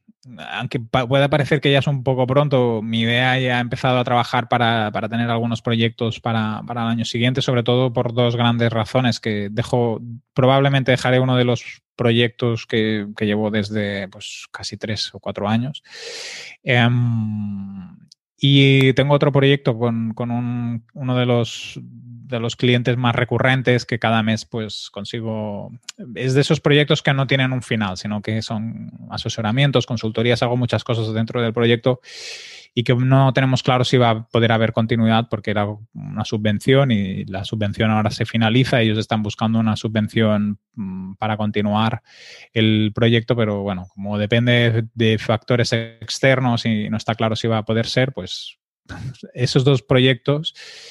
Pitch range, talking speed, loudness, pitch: 110-130 Hz, 165 wpm, -19 LUFS, 120 Hz